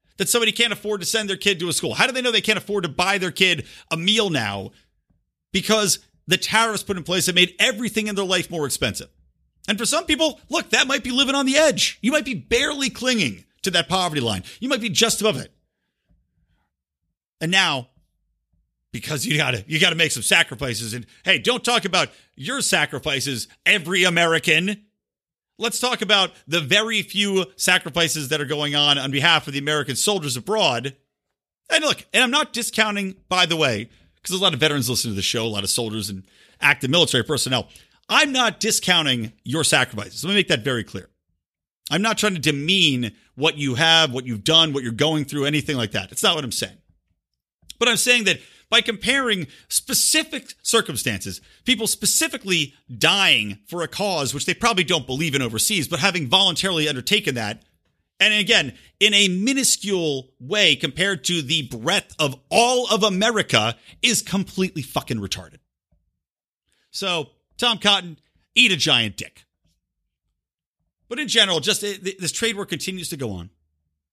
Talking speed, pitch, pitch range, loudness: 185 wpm, 170 Hz, 130-210 Hz, -19 LUFS